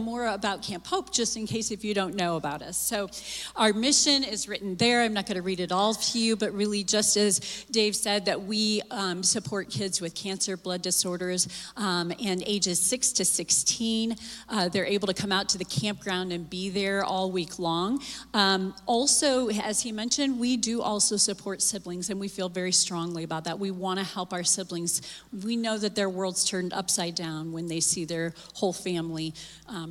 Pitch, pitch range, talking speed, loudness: 195 Hz, 180-215 Hz, 205 wpm, -27 LUFS